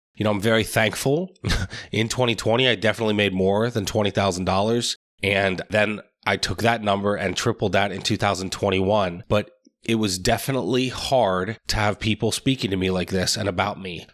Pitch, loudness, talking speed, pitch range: 105 Hz, -22 LUFS, 170 wpm, 95-115 Hz